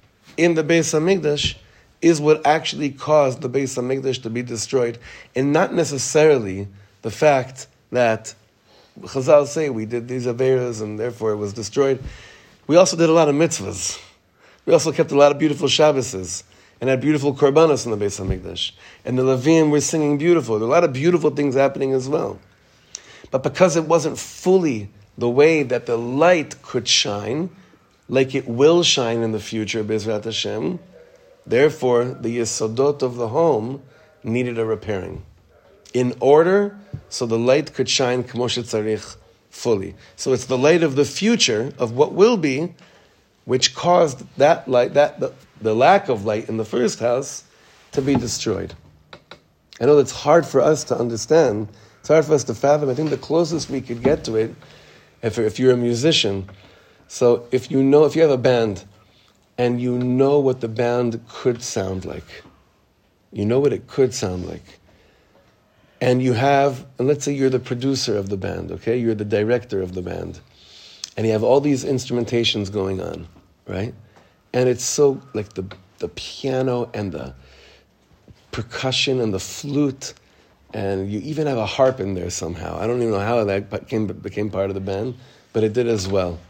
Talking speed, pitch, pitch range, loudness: 180 wpm, 125 Hz, 105-145 Hz, -19 LUFS